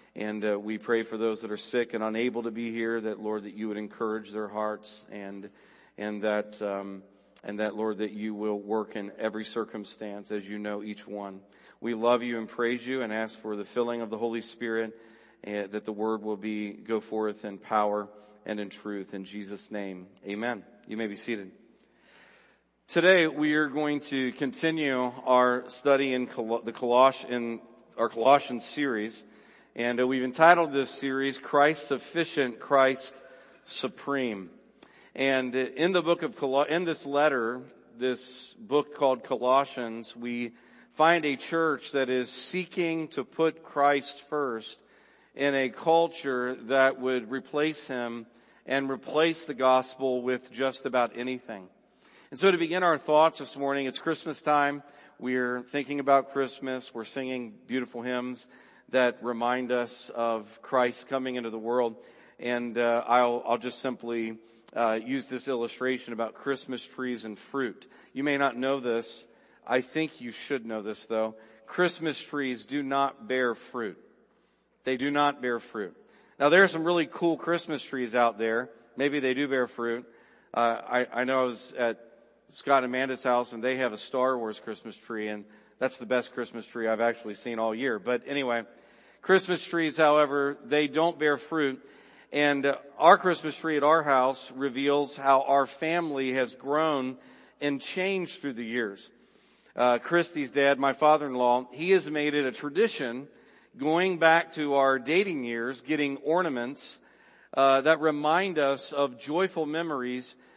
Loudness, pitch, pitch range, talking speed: -28 LUFS, 125 Hz, 115-140 Hz, 165 wpm